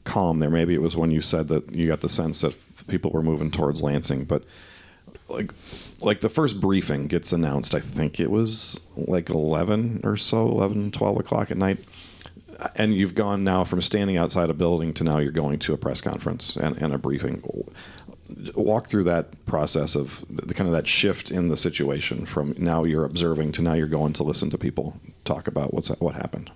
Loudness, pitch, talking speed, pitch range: -24 LUFS, 85 Hz, 205 wpm, 80-100 Hz